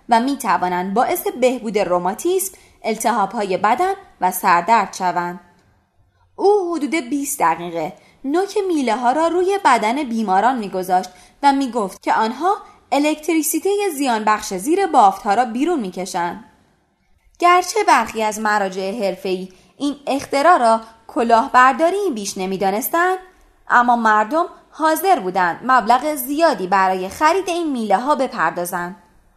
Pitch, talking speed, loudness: 245 Hz, 120 wpm, -18 LUFS